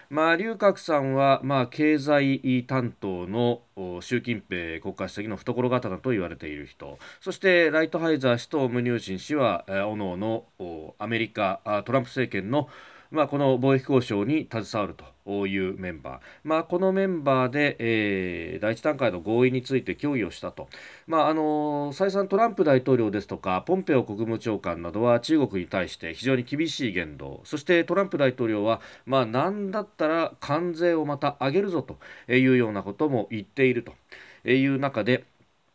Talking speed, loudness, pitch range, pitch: 345 characters per minute, -25 LUFS, 105-150 Hz, 125 Hz